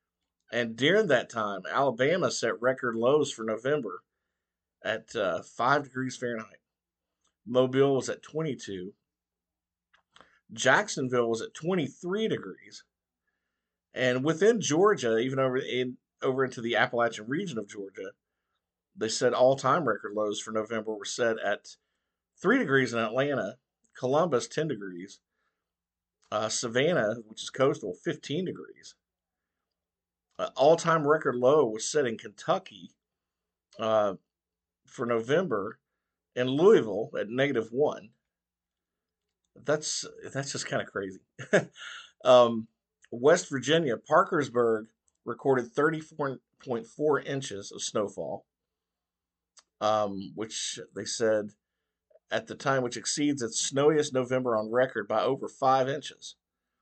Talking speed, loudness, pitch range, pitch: 120 wpm, -28 LUFS, 110-135 Hz, 125 Hz